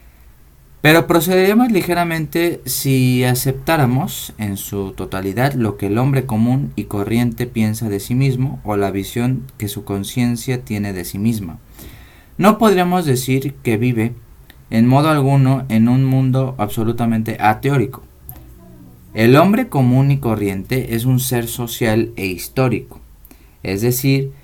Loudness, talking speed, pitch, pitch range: -17 LUFS, 135 wpm, 120 Hz, 105-135 Hz